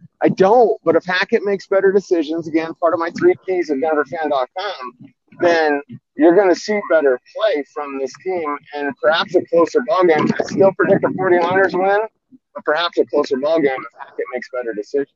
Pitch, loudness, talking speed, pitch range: 175 Hz, -17 LUFS, 195 wpm, 155-205 Hz